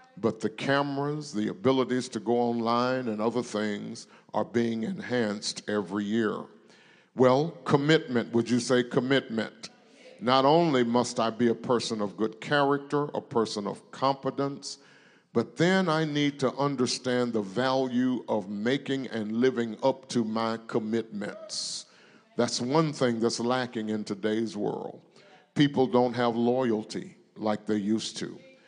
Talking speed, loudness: 140 wpm, -28 LUFS